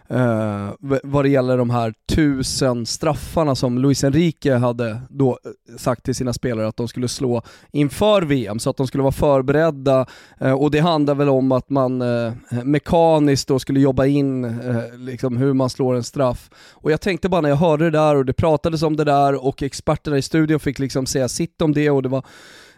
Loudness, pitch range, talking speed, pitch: -19 LUFS, 125-150 Hz, 205 wpm, 135 Hz